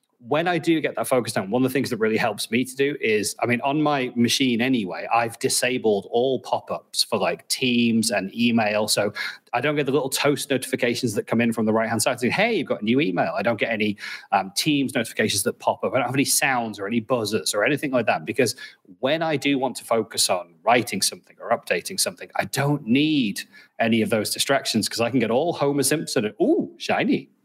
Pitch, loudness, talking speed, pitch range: 130 Hz, -22 LUFS, 235 wpm, 115-145 Hz